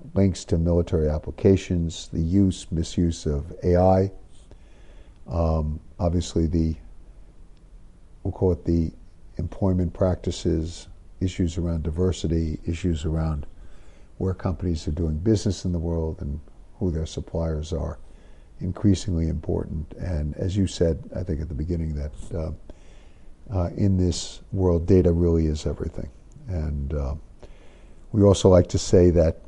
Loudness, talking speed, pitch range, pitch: -24 LUFS, 130 wpm, 80-90 Hz, 85 Hz